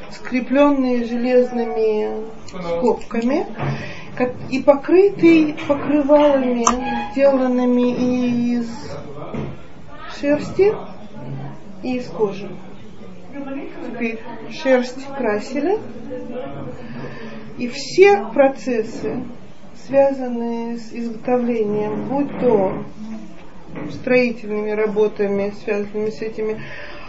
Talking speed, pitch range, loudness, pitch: 65 wpm, 220-275 Hz, -19 LUFS, 245 Hz